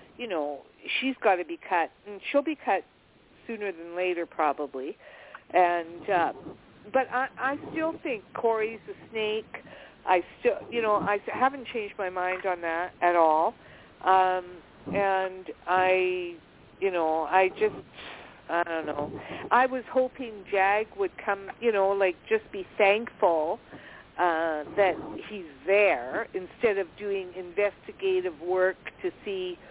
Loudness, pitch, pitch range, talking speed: -28 LUFS, 195 Hz, 180-245 Hz, 145 wpm